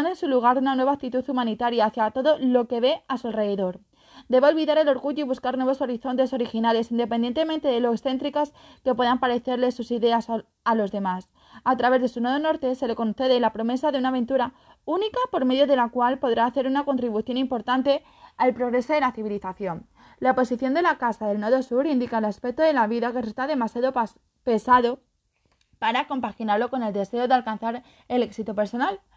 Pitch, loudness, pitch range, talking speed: 250 Hz, -24 LUFS, 230-270 Hz, 195 wpm